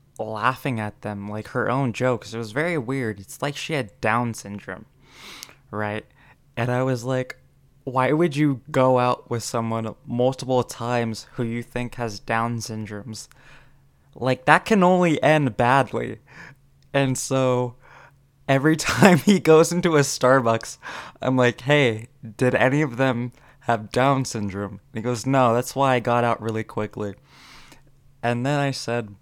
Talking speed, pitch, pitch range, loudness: 160 wpm, 125 Hz, 115-140 Hz, -22 LUFS